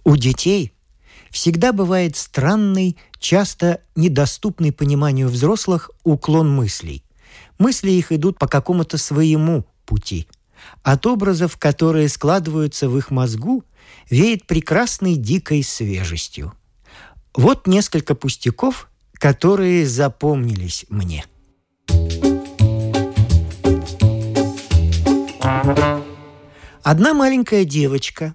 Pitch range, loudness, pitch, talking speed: 110-175 Hz, -18 LUFS, 145 Hz, 80 wpm